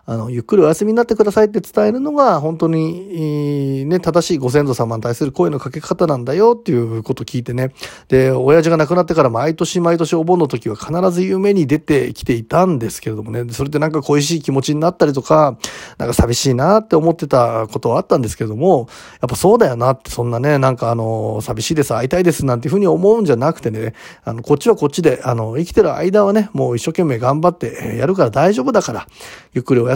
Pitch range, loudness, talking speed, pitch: 125-175 Hz, -16 LUFS, 490 characters per minute, 150 Hz